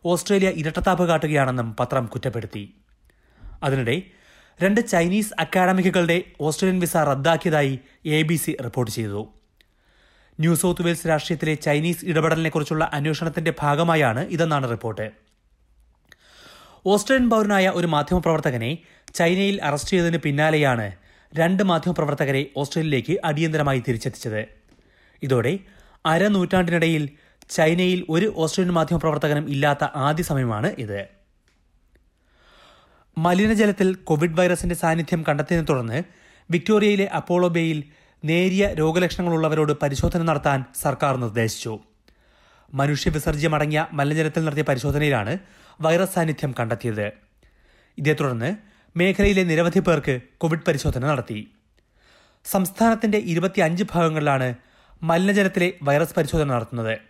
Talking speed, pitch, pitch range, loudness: 90 wpm, 160 Hz, 135-175 Hz, -22 LUFS